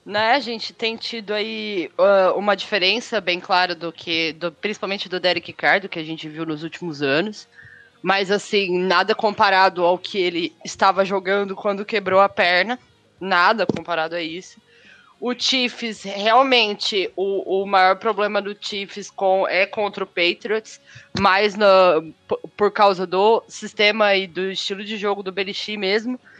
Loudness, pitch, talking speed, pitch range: -20 LUFS, 200 Hz, 160 wpm, 185-215 Hz